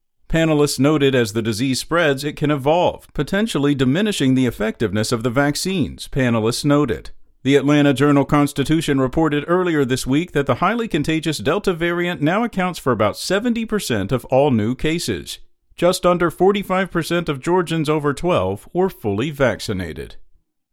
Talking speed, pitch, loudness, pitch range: 145 wpm, 145 Hz, -19 LUFS, 130-175 Hz